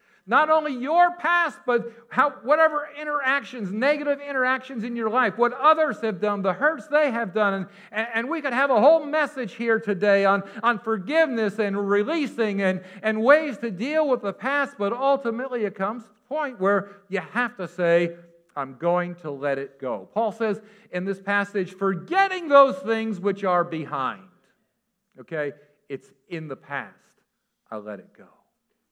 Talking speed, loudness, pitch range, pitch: 170 wpm, -23 LUFS, 195-275 Hz, 220 Hz